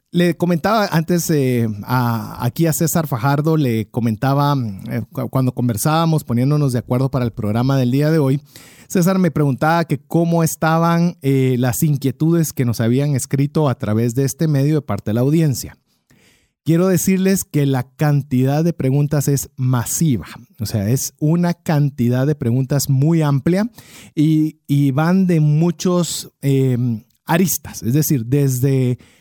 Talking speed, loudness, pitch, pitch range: 155 wpm, -17 LUFS, 140 Hz, 125-160 Hz